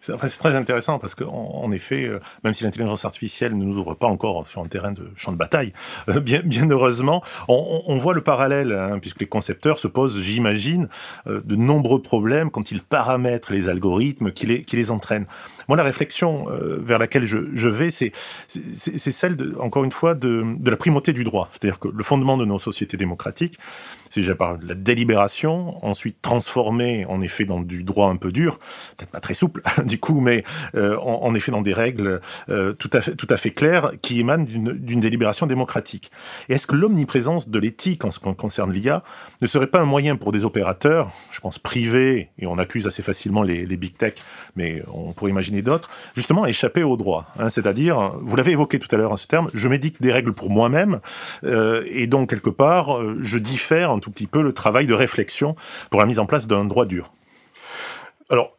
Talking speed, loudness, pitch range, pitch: 210 wpm, -21 LUFS, 105-140 Hz, 120 Hz